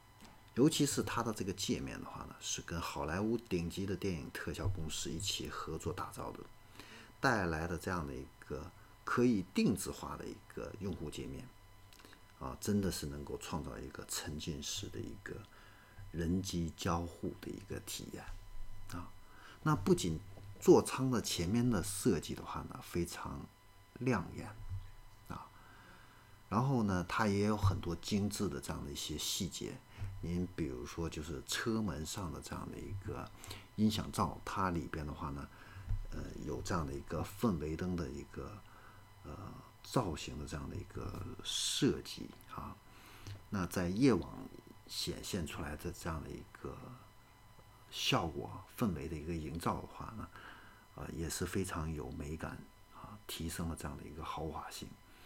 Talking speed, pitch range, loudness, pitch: 230 characters per minute, 85-105 Hz, -38 LUFS, 95 Hz